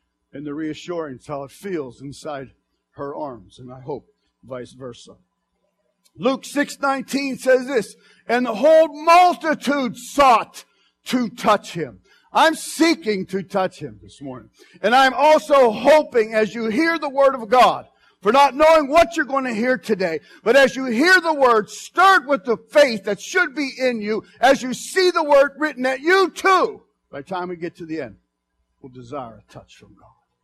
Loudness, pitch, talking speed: -18 LUFS, 245 Hz, 180 wpm